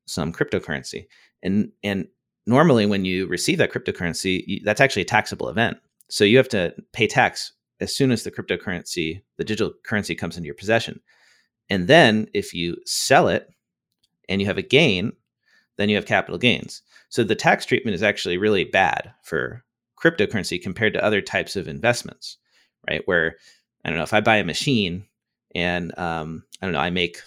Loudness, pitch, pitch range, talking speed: -21 LUFS, 95 Hz, 85-105 Hz, 185 wpm